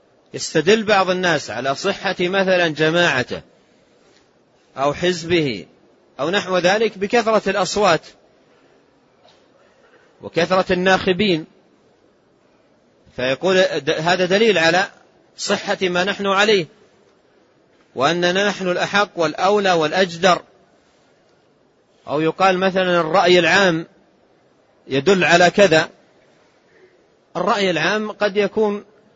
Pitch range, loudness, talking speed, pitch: 170-200 Hz, -17 LUFS, 85 wpm, 185 Hz